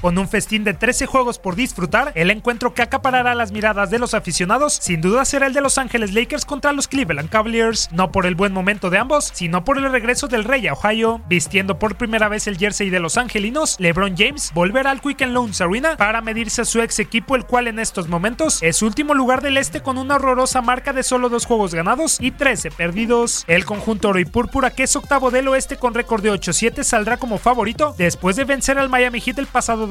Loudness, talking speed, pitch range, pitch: -18 LUFS, 230 wpm, 205-265 Hz, 230 Hz